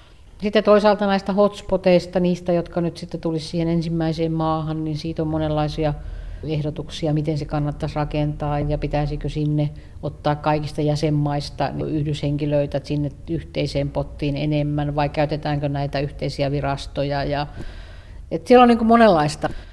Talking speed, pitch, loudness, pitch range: 130 wpm, 150 Hz, -21 LUFS, 145-165 Hz